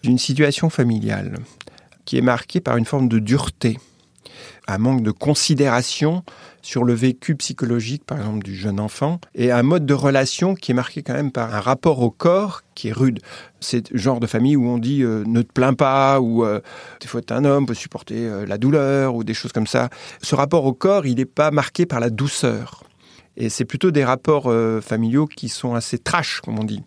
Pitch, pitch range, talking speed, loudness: 125 Hz, 115-145 Hz, 220 wpm, -19 LUFS